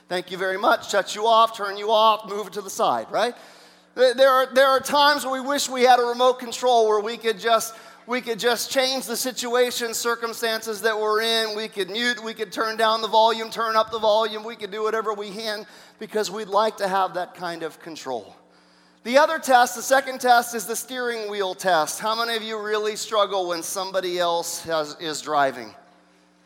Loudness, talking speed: -22 LUFS, 215 wpm